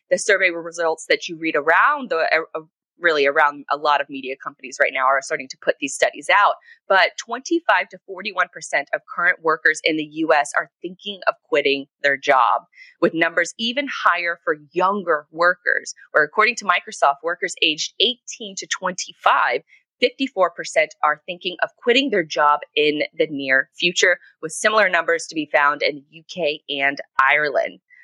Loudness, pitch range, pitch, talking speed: -19 LUFS, 150-215 Hz, 170 Hz, 175 wpm